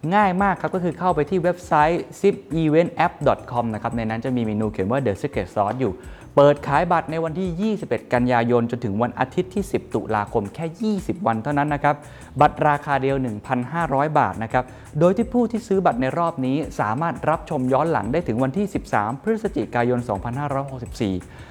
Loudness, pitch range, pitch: -22 LUFS, 120-170 Hz, 145 Hz